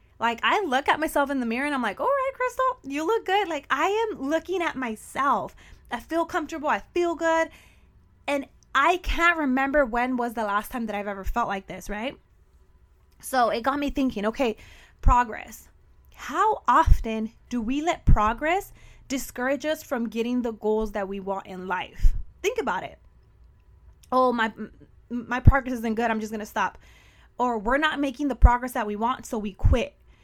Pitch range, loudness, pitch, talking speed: 225-315 Hz, -26 LUFS, 255 Hz, 190 wpm